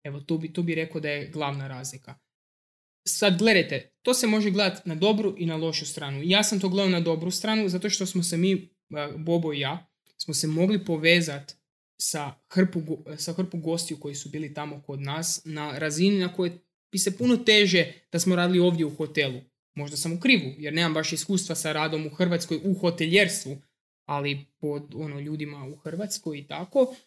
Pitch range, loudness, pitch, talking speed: 150-185 Hz, -25 LUFS, 165 Hz, 195 wpm